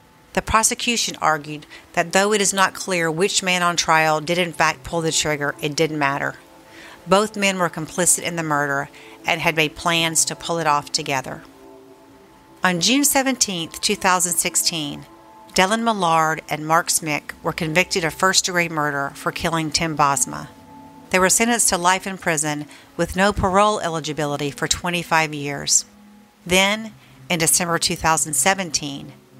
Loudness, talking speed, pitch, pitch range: -19 LUFS, 155 wpm, 170 Hz, 150-190 Hz